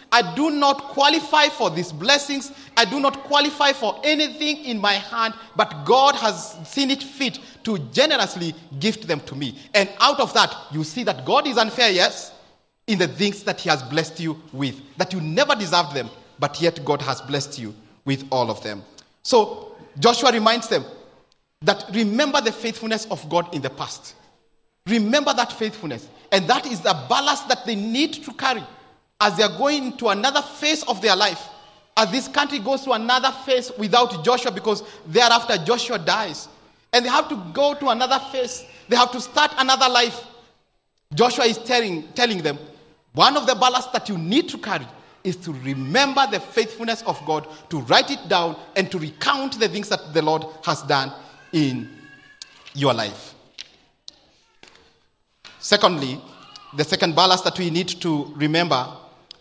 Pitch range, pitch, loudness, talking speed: 160-255 Hz, 215 Hz, -20 LUFS, 175 wpm